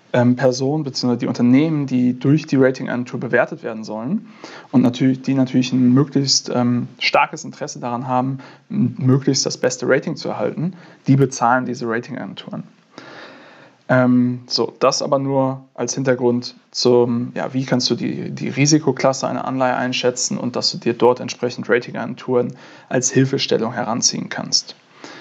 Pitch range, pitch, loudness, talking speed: 125-140 Hz, 130 Hz, -18 LUFS, 145 wpm